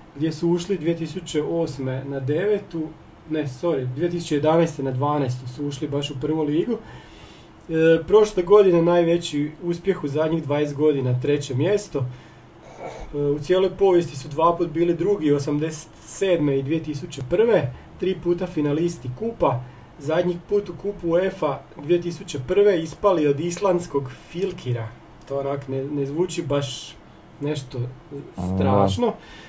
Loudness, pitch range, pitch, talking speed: -23 LUFS, 140-175 Hz, 155 Hz, 130 wpm